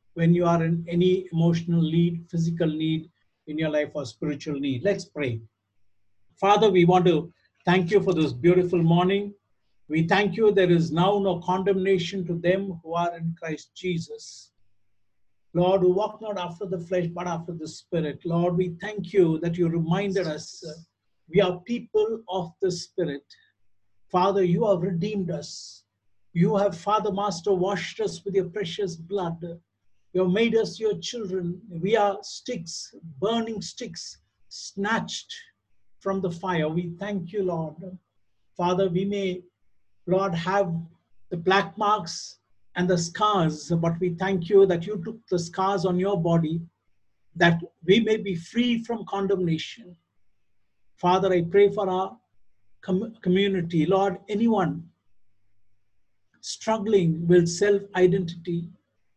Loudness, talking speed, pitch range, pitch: -25 LUFS, 145 wpm, 160-195 Hz, 180 Hz